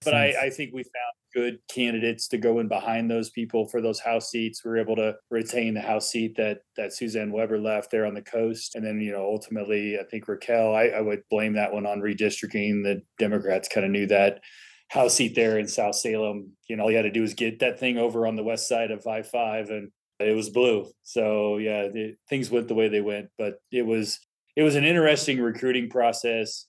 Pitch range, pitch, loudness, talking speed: 105-115 Hz, 110 Hz, -26 LUFS, 235 wpm